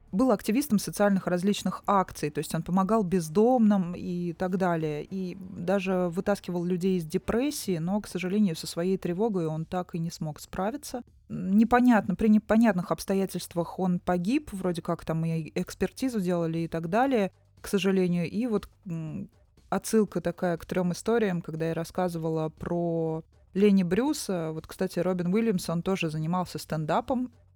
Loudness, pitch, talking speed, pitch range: -28 LUFS, 185 Hz, 150 wpm, 170-205 Hz